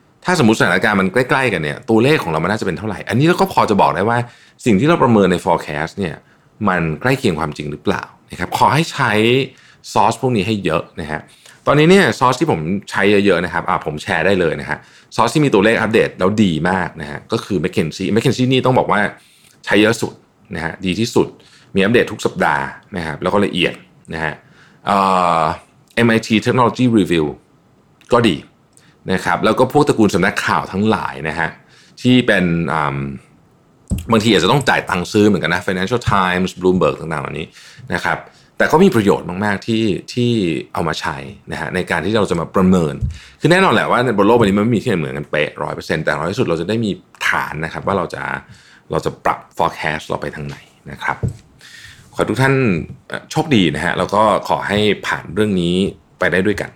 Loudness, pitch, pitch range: -16 LUFS, 100 Hz, 85-120 Hz